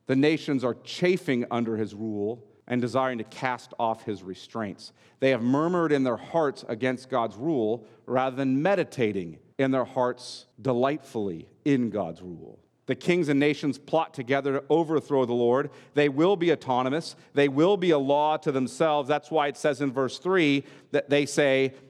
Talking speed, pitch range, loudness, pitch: 175 wpm, 125-145 Hz, -26 LUFS, 135 Hz